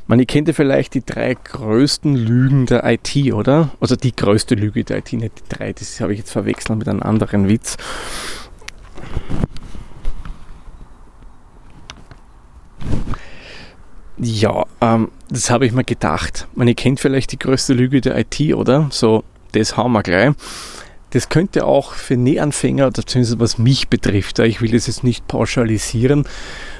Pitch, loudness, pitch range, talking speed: 120 Hz, -17 LUFS, 110-130 Hz, 150 wpm